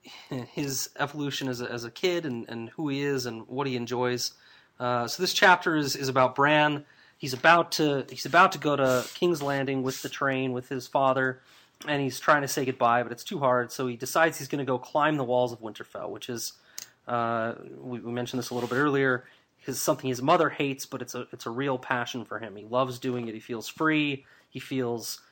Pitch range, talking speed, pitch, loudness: 120-145 Hz, 225 wpm, 130 Hz, -27 LUFS